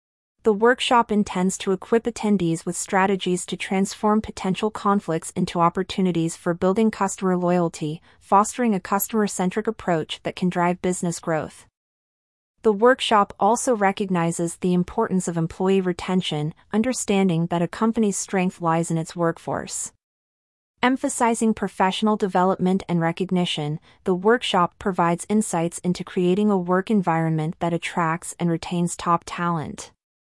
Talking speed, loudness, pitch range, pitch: 130 wpm, -22 LUFS, 170-210 Hz, 185 Hz